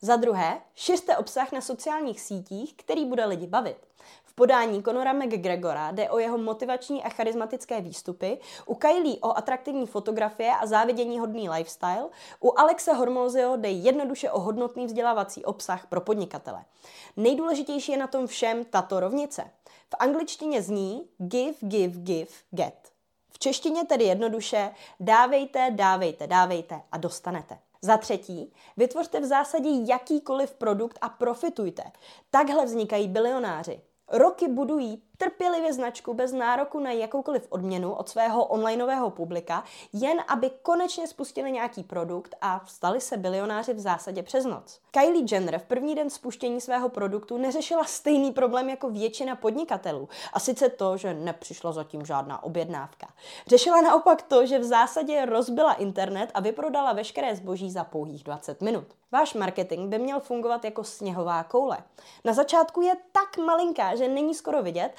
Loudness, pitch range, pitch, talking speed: -26 LUFS, 195-275 Hz, 240 Hz, 145 wpm